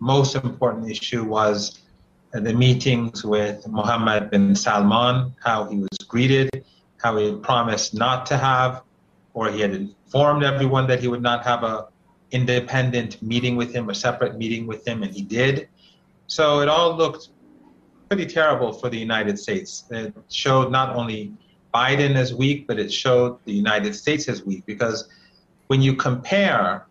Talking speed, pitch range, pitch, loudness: 165 wpm, 110-135 Hz, 125 Hz, -21 LUFS